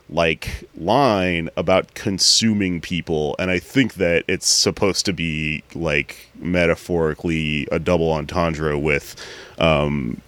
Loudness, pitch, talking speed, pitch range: -19 LUFS, 85 Hz, 115 wpm, 80-90 Hz